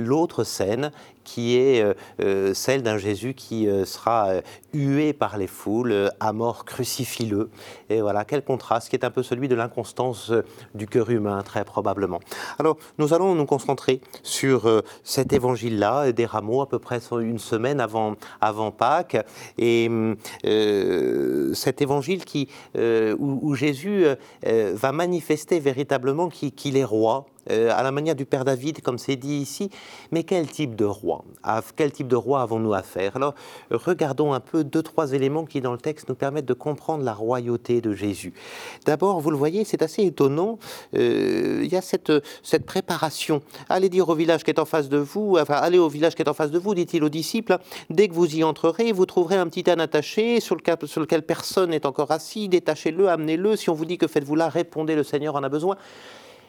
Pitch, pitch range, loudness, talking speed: 145 Hz, 120-170 Hz, -23 LUFS, 185 wpm